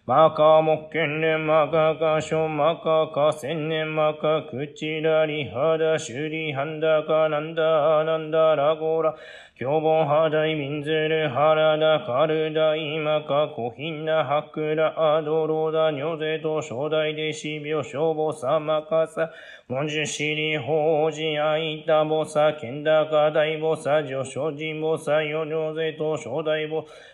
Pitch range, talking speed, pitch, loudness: 155-160 Hz, 305 characters per minute, 155 Hz, -23 LUFS